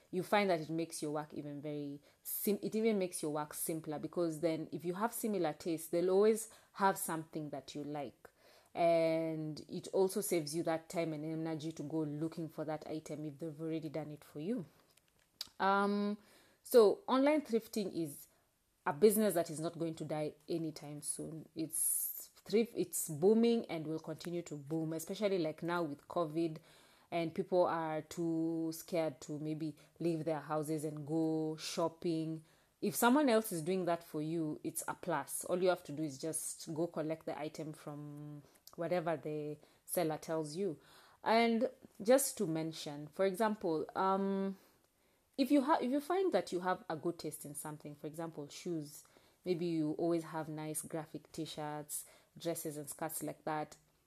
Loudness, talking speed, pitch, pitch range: -37 LUFS, 175 wpm, 165 Hz, 155-185 Hz